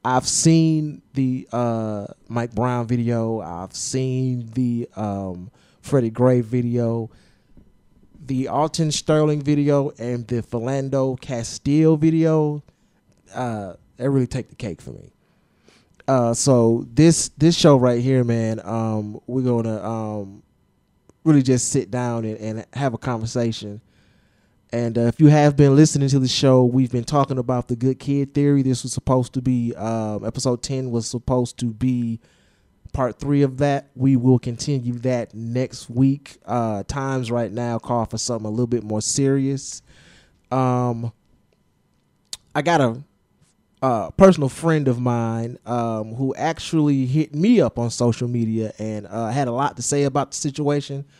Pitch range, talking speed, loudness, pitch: 115-135 Hz, 155 wpm, -21 LUFS, 125 Hz